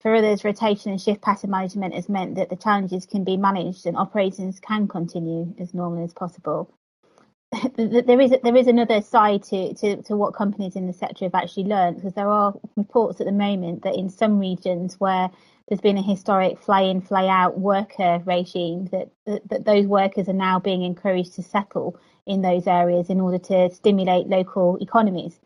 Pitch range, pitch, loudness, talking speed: 180-205 Hz, 195 Hz, -22 LUFS, 185 wpm